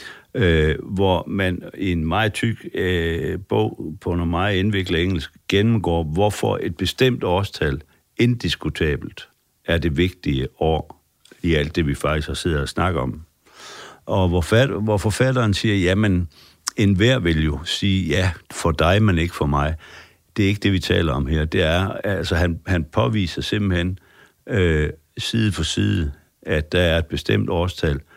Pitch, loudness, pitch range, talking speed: 90 Hz, -21 LUFS, 80-100 Hz, 160 wpm